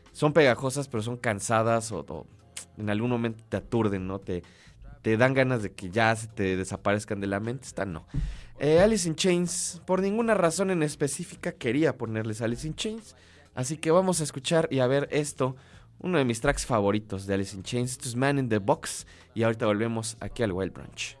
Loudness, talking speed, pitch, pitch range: -27 LUFS, 205 wpm, 120 Hz, 105-145 Hz